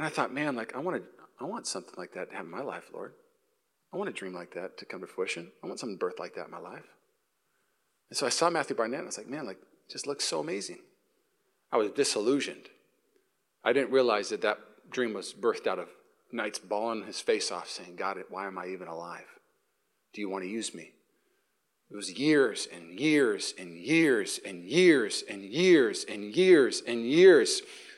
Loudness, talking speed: -29 LUFS, 215 wpm